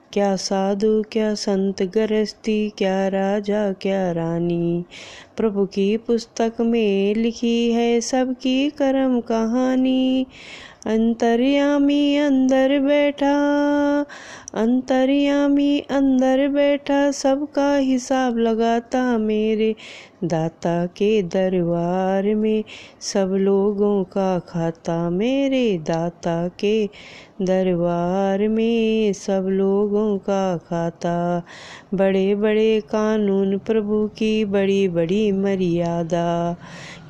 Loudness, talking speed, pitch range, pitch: -20 LUFS, 80 wpm, 190-250 Hz, 215 Hz